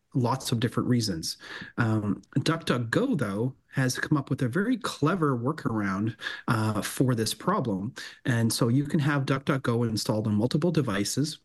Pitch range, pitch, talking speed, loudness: 110-145 Hz, 130 Hz, 150 wpm, -27 LUFS